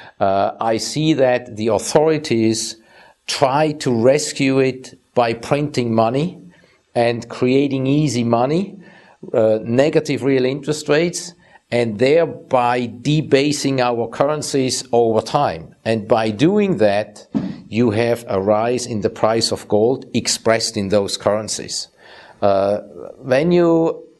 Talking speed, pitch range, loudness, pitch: 120 wpm, 115-150 Hz, -18 LUFS, 125 Hz